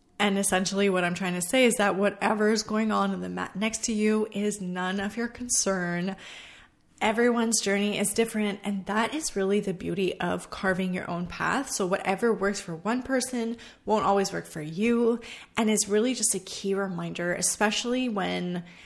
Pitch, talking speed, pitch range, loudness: 205 Hz, 190 wpm, 185-225 Hz, -27 LUFS